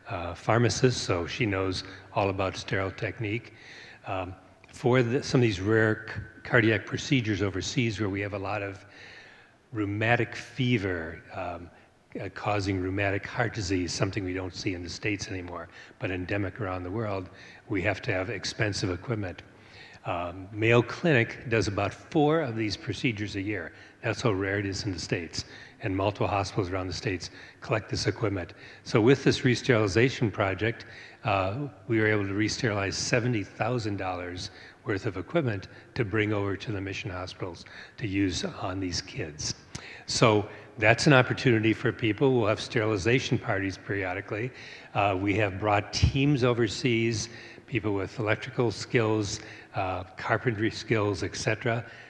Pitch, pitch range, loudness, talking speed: 105 Hz, 95-120 Hz, -28 LUFS, 155 wpm